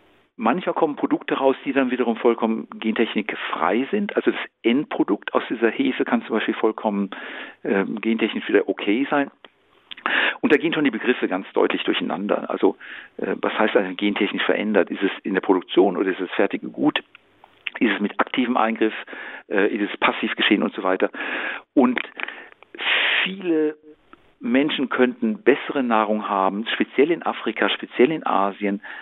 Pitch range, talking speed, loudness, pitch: 105-135 Hz, 160 wpm, -22 LUFS, 115 Hz